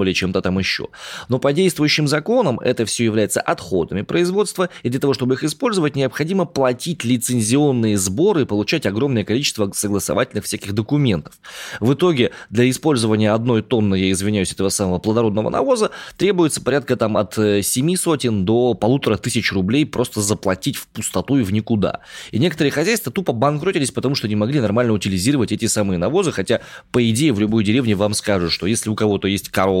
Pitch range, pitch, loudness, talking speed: 105-140 Hz, 115 Hz, -18 LUFS, 175 wpm